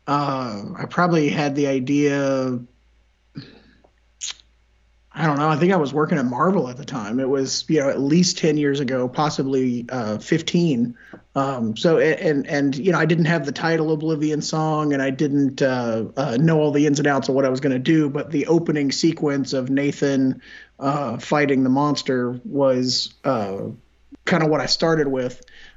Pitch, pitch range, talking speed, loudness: 140 Hz, 130-155 Hz, 190 wpm, -21 LUFS